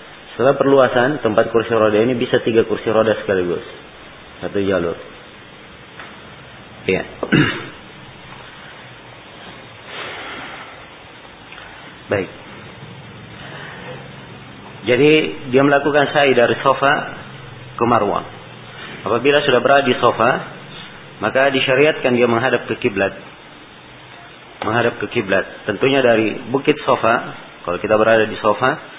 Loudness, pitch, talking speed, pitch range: -16 LUFS, 120 Hz, 95 wpm, 110-135 Hz